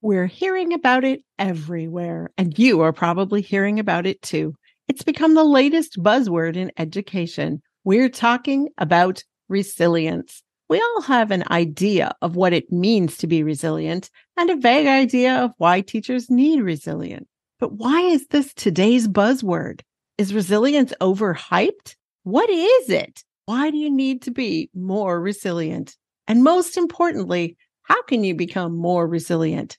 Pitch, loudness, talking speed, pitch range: 205 Hz, -19 LUFS, 150 wpm, 175-265 Hz